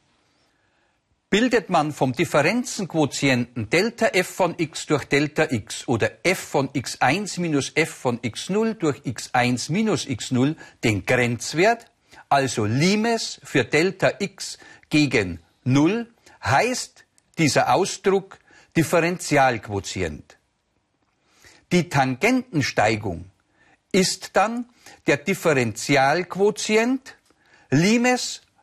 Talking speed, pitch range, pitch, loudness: 90 wpm, 130-195 Hz, 150 Hz, -22 LUFS